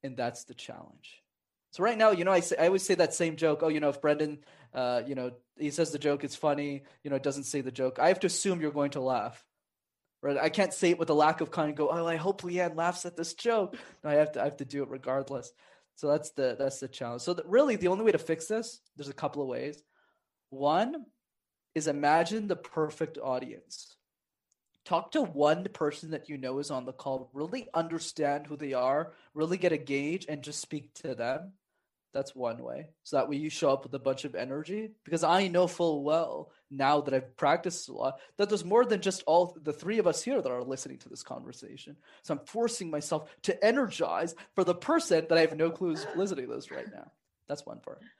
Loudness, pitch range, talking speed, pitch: -30 LUFS, 140-180 Hz, 240 wpm, 155 Hz